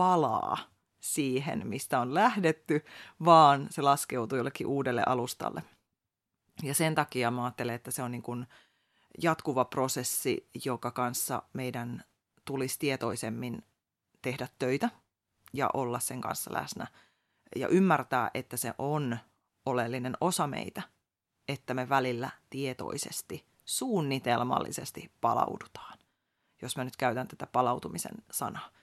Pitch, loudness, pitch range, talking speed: 130 Hz, -31 LUFS, 120-140 Hz, 115 wpm